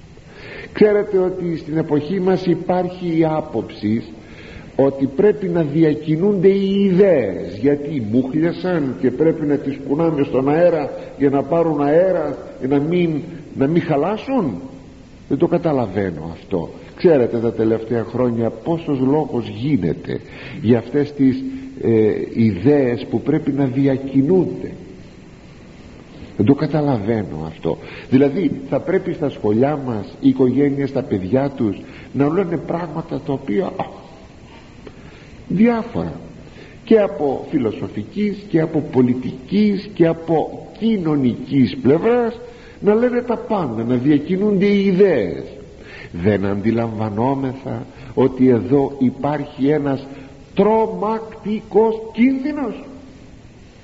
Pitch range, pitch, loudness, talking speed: 130-180 Hz, 145 Hz, -18 LUFS, 115 wpm